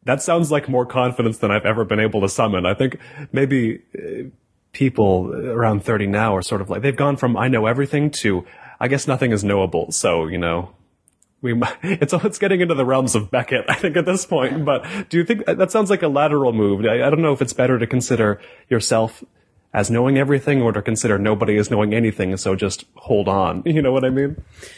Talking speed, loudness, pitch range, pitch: 225 wpm, -19 LUFS, 105-145 Hz, 125 Hz